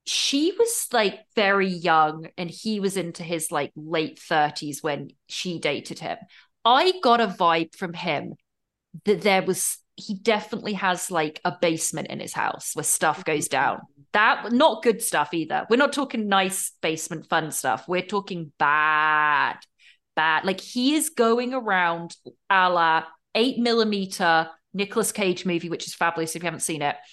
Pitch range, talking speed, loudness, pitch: 165-215 Hz, 165 wpm, -23 LUFS, 180 Hz